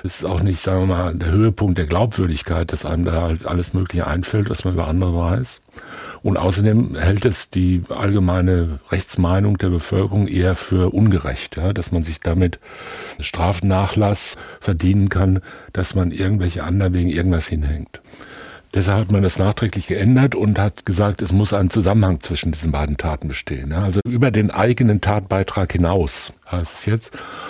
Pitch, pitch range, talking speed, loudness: 95 Hz, 85-100 Hz, 170 wpm, -19 LUFS